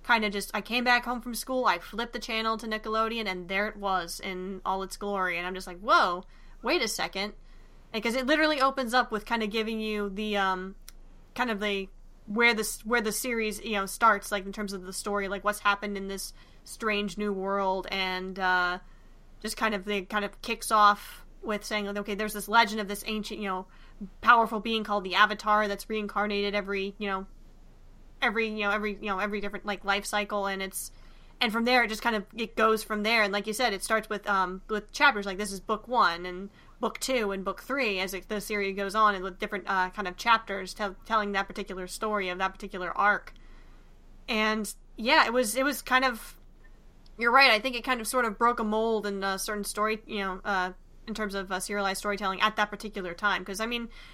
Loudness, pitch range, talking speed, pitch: -28 LUFS, 195-225 Hz, 230 wpm, 210 Hz